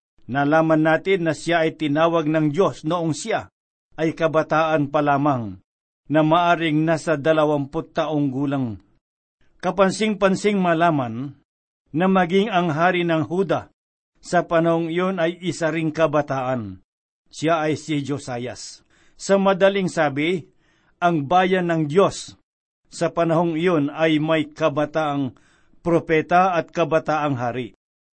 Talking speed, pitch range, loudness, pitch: 120 wpm, 150-170 Hz, -21 LUFS, 160 Hz